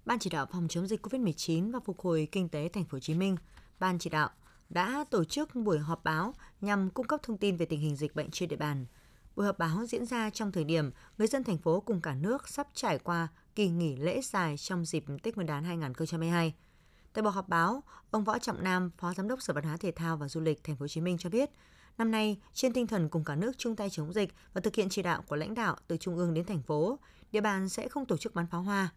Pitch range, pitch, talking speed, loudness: 165-220 Hz, 180 Hz, 265 wpm, -33 LUFS